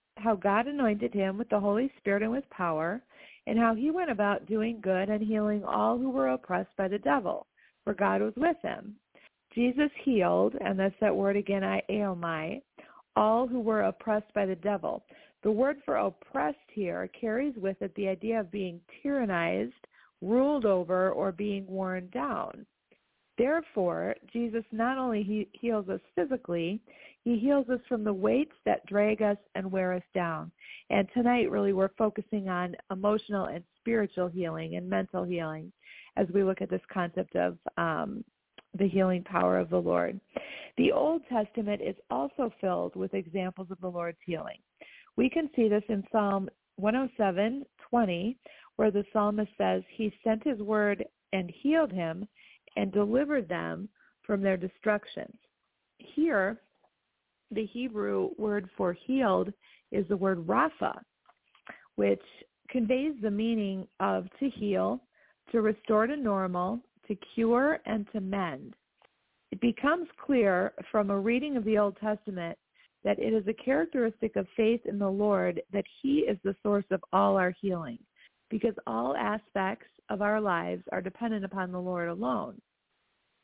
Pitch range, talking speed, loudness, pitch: 190-235 Hz, 155 wpm, -30 LUFS, 210 Hz